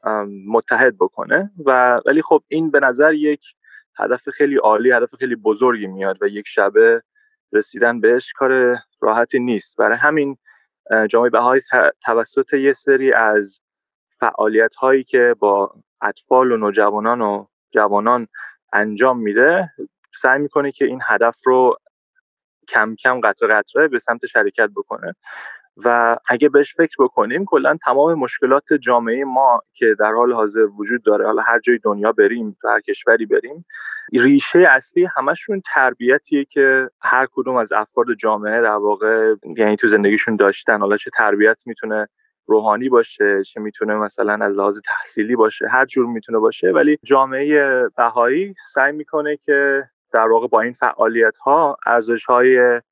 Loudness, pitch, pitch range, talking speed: -16 LUFS, 130 Hz, 115-165 Hz, 145 wpm